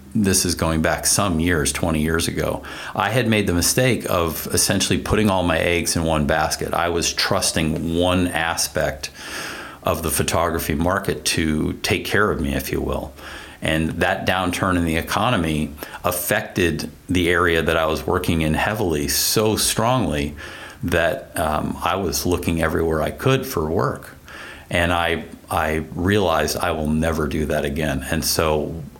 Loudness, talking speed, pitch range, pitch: -20 LUFS, 165 wpm, 80-90 Hz, 85 Hz